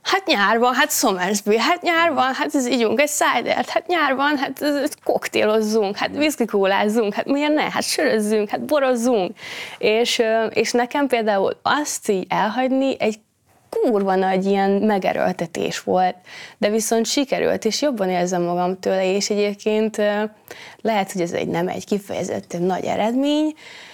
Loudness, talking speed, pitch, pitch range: -20 LUFS, 150 wpm, 225 Hz, 205-280 Hz